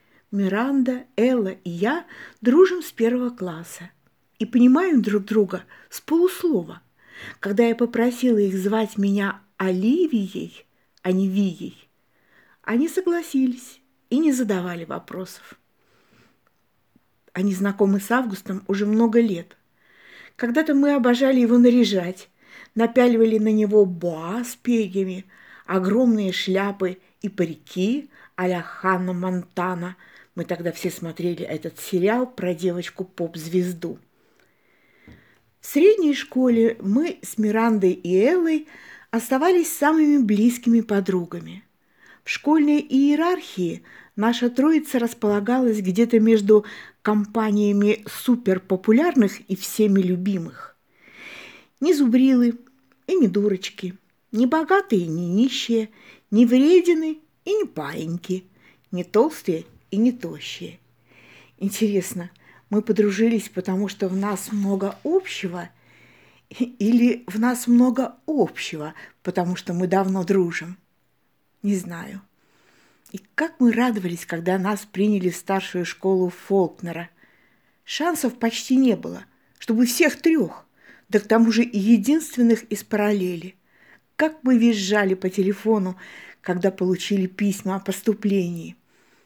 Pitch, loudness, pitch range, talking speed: 210 Hz, -21 LUFS, 190-245 Hz, 110 wpm